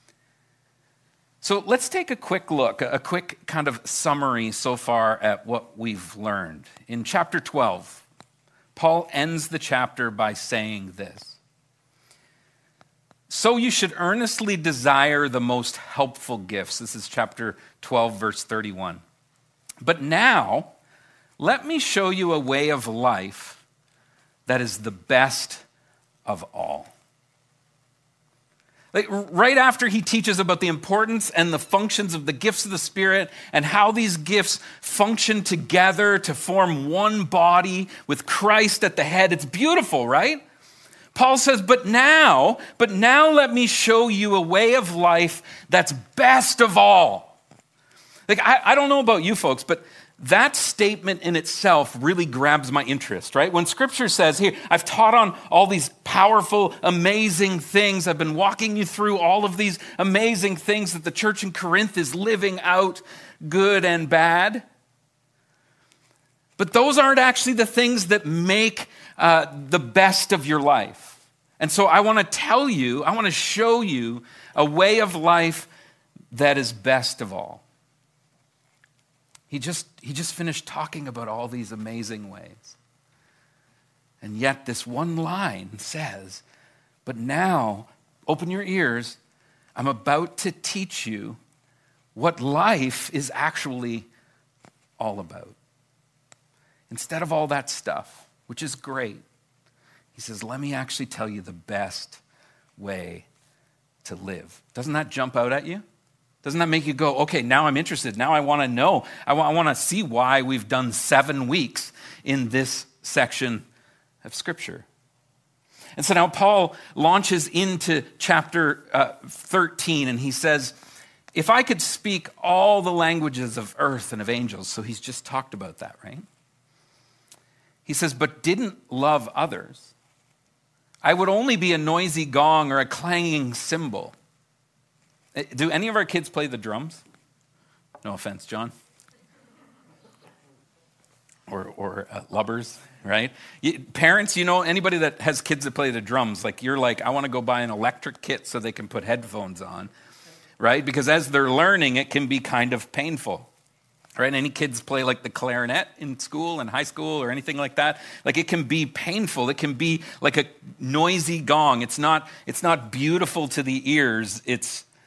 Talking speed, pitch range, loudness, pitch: 155 wpm, 130-180 Hz, -21 LUFS, 150 Hz